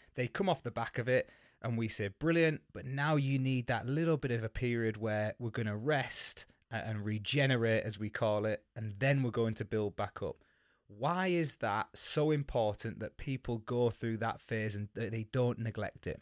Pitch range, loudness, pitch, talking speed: 110-135 Hz, -35 LUFS, 115 Hz, 205 wpm